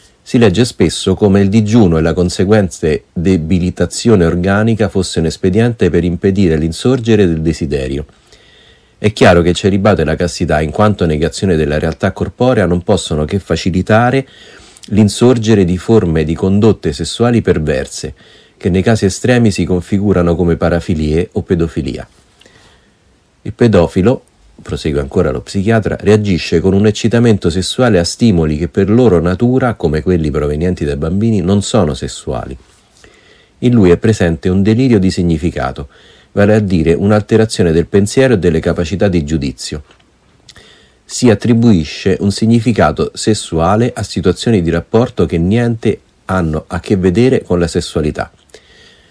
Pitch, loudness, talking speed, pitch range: 95 Hz, -12 LUFS, 140 wpm, 85-110 Hz